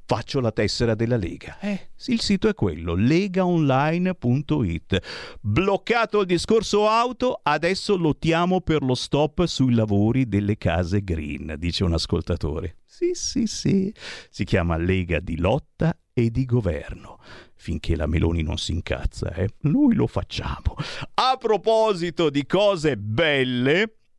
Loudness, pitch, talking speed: -23 LUFS, 130 Hz, 135 wpm